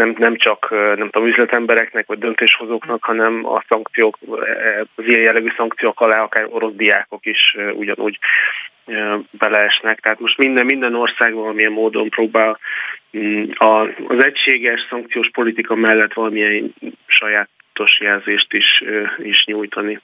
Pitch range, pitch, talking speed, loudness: 110-115 Hz, 110 Hz, 125 wpm, -15 LUFS